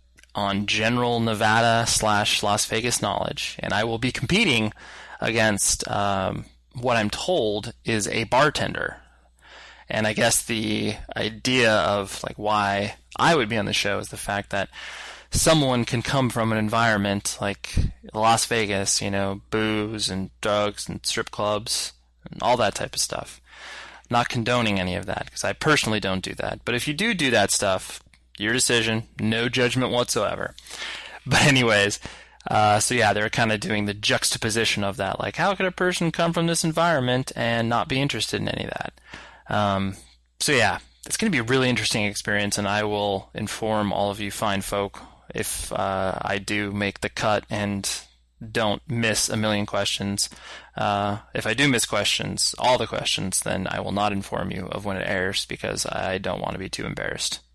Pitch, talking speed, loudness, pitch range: 105 Hz, 180 wpm, -23 LUFS, 100-120 Hz